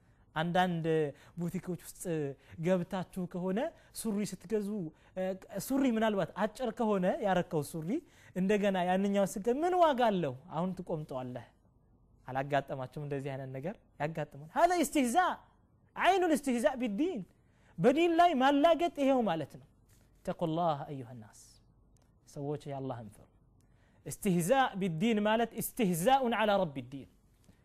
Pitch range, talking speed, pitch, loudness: 145-230 Hz, 125 wpm, 185 Hz, -32 LUFS